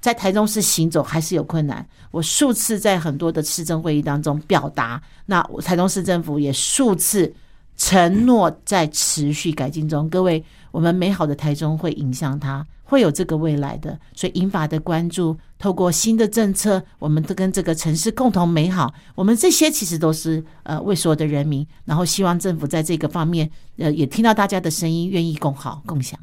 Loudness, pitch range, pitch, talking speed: -19 LUFS, 150-190 Hz, 165 Hz, 295 characters per minute